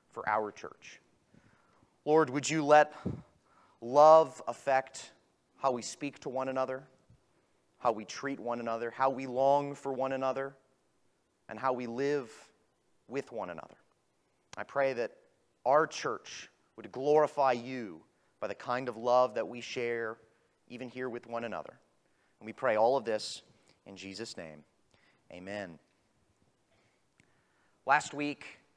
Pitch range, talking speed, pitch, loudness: 120-140 Hz, 140 wpm, 130 Hz, -31 LUFS